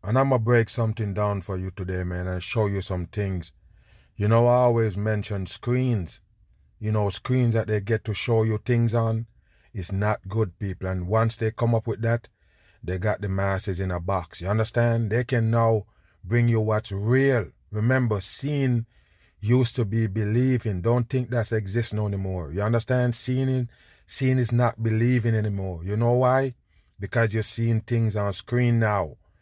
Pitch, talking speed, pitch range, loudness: 110 Hz, 175 wpm, 100-120 Hz, -24 LUFS